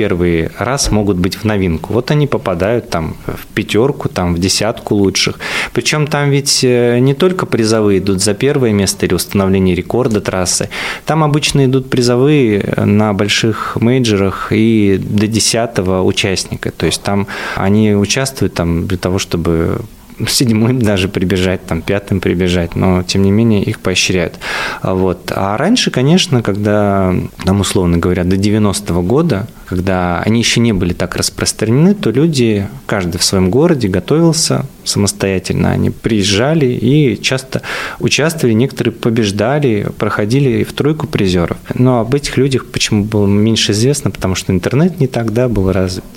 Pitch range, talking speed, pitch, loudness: 95-125 Hz, 145 wpm, 105 Hz, -13 LUFS